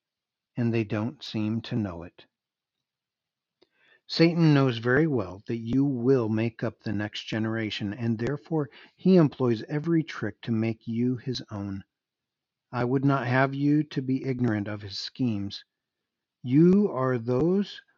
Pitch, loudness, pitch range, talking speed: 125 Hz, -26 LUFS, 110-140 Hz, 145 wpm